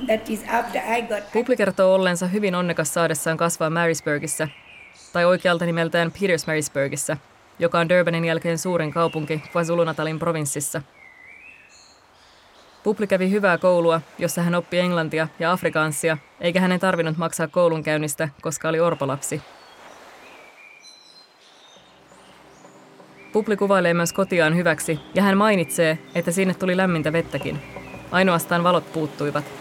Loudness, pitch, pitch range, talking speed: -22 LUFS, 170 Hz, 160-185 Hz, 110 wpm